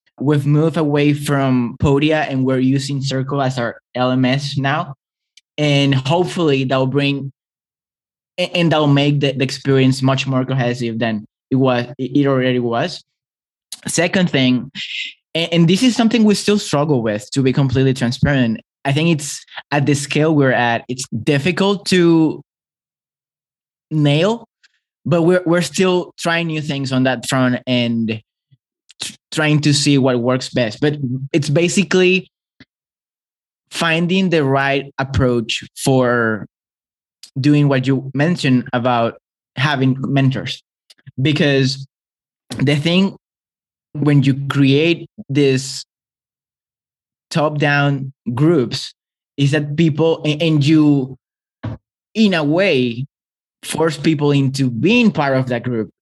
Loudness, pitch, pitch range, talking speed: -16 LUFS, 140 Hz, 130-160 Hz, 125 wpm